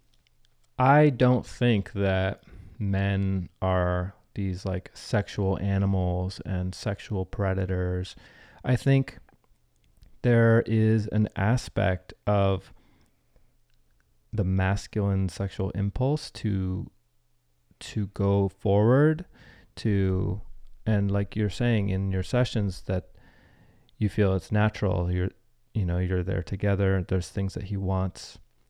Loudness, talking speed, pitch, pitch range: -27 LUFS, 110 wpm, 95 Hz, 95-105 Hz